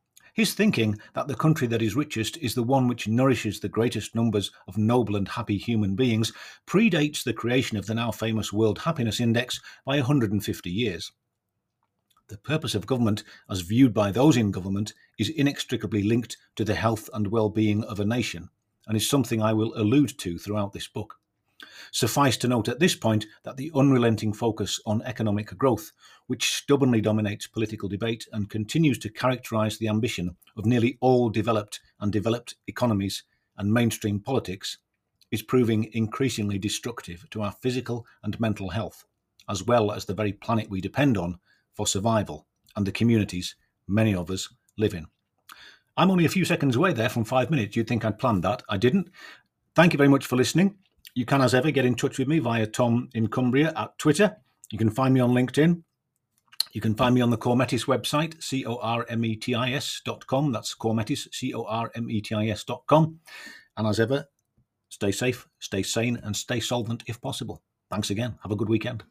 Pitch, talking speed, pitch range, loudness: 115 Hz, 195 wpm, 105-130 Hz, -25 LUFS